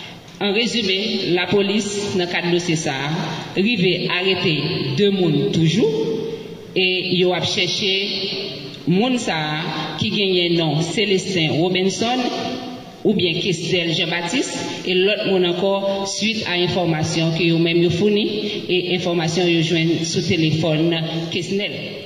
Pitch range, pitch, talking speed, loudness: 165-195 Hz, 180 Hz, 130 wpm, -19 LUFS